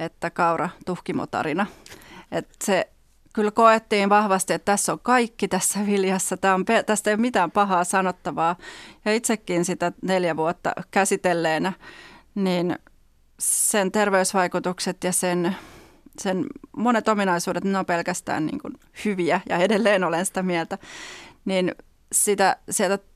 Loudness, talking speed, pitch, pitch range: -23 LUFS, 130 wpm, 190 Hz, 180-210 Hz